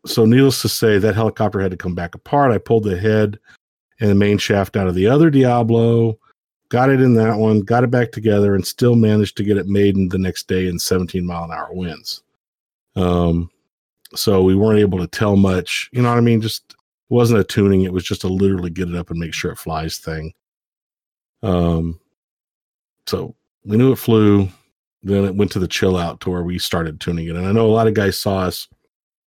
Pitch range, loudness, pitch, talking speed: 90-110 Hz, -17 LUFS, 100 Hz, 225 wpm